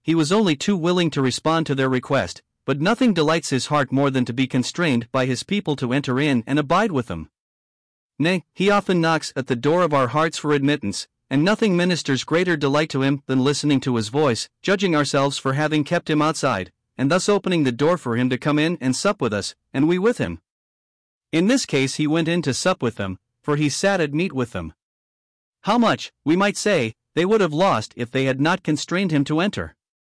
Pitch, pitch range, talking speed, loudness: 145 Hz, 125-170 Hz, 225 wpm, -21 LUFS